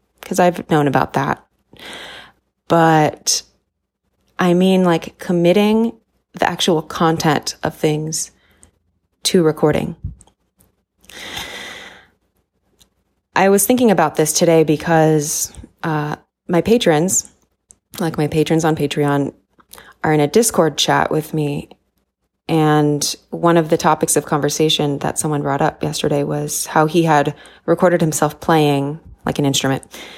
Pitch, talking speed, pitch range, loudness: 155 Hz, 120 wpm, 150-170 Hz, -16 LUFS